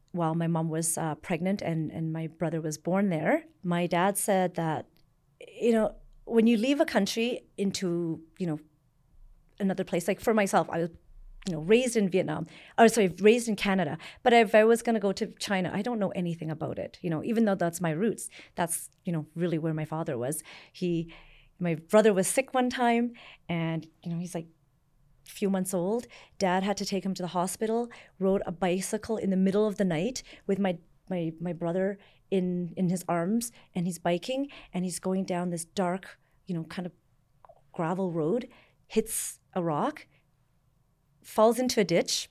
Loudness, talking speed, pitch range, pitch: -29 LUFS, 195 wpm, 165-215 Hz, 185 Hz